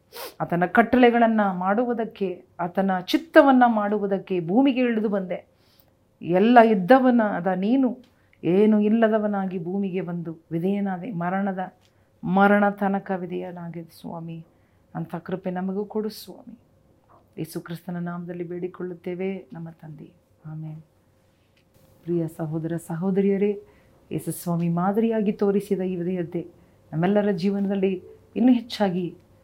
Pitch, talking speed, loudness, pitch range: 185 Hz, 95 wpm, -23 LUFS, 170-205 Hz